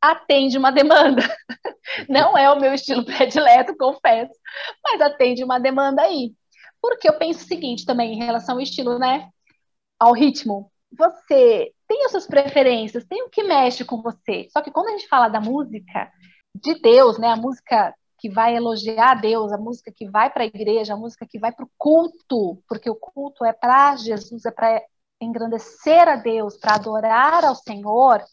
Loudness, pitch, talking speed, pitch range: -18 LUFS, 255 Hz, 180 wpm, 230-300 Hz